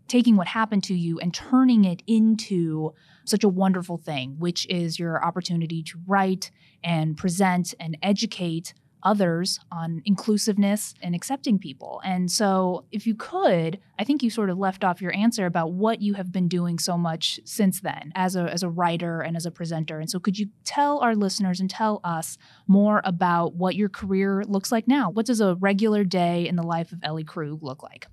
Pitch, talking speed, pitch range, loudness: 185 Hz, 200 wpm, 170-205 Hz, -24 LUFS